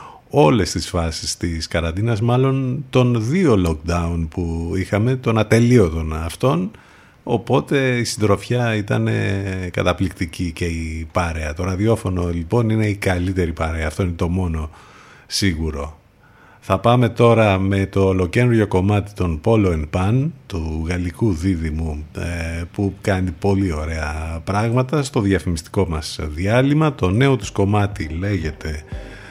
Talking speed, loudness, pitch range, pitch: 125 wpm, -19 LUFS, 85-110 Hz, 95 Hz